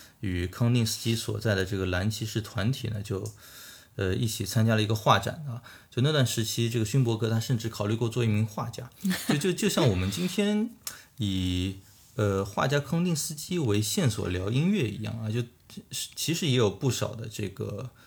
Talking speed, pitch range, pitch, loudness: 280 characters per minute, 105-130 Hz, 115 Hz, -28 LUFS